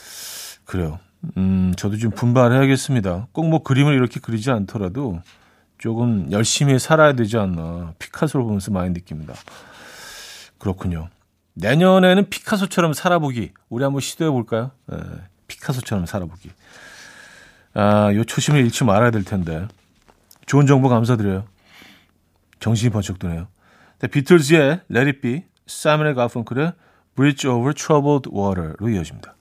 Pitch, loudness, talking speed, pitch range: 115 Hz, -19 LUFS, 340 characters per minute, 95-140 Hz